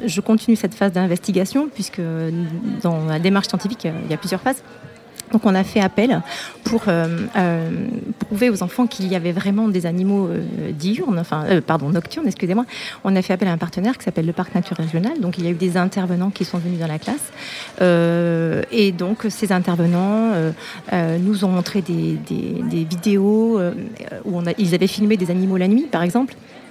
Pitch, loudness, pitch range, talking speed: 190 Hz, -20 LUFS, 175-215 Hz, 205 wpm